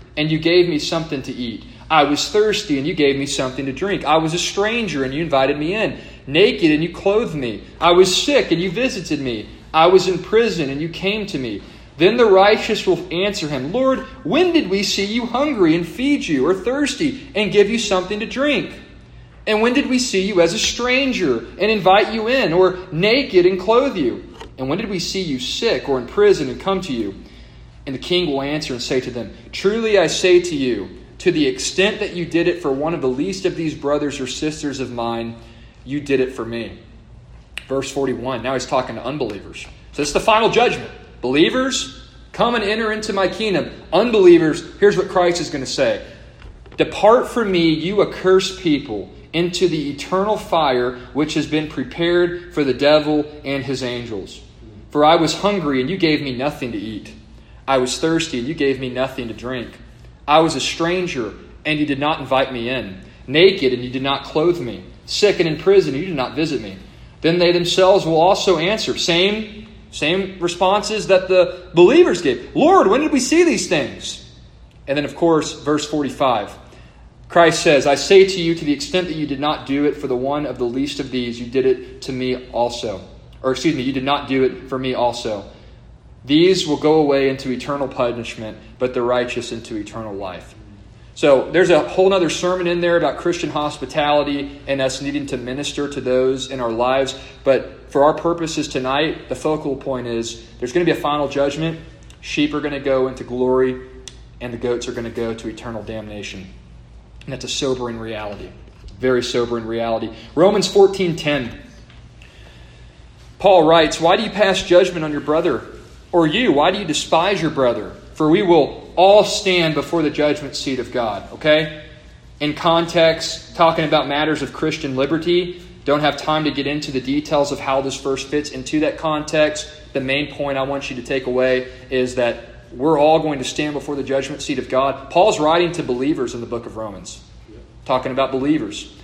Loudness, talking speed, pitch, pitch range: -18 LUFS, 200 wpm, 150 Hz, 130-180 Hz